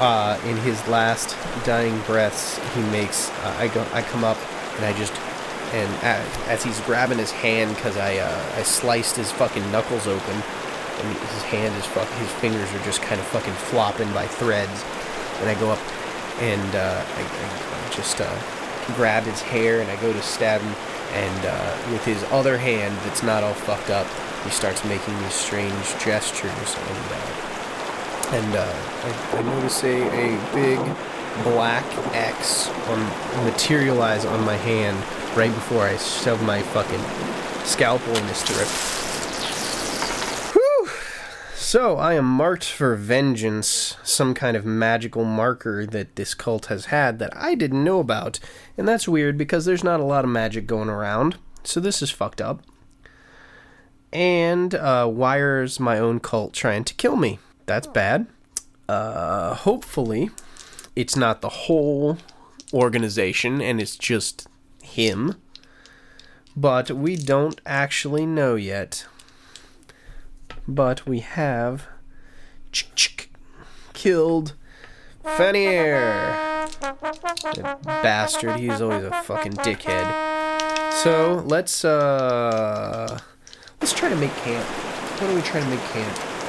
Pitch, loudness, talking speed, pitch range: 120 Hz, -23 LUFS, 140 wpm, 110-150 Hz